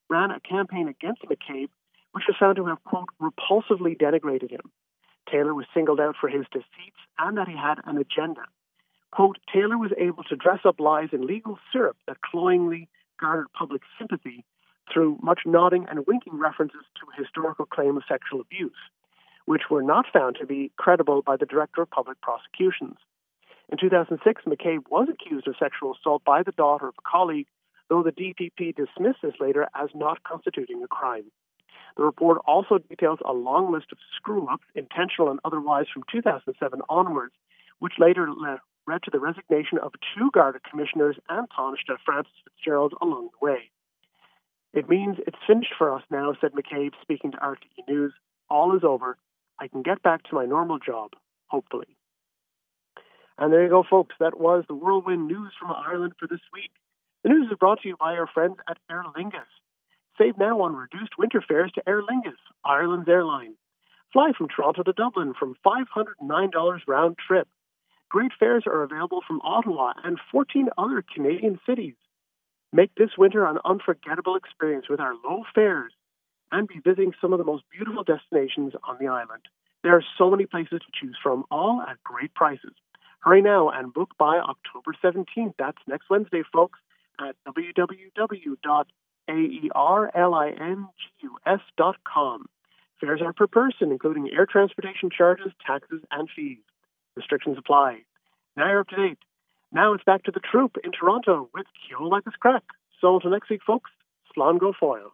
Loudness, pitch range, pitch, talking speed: -24 LUFS, 155-205 Hz, 180 Hz, 170 wpm